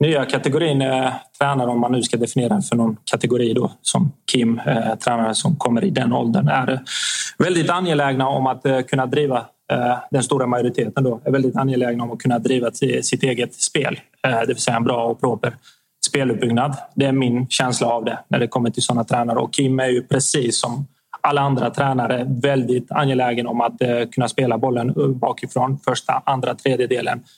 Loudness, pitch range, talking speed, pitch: -19 LUFS, 120-135 Hz, 180 wpm, 125 Hz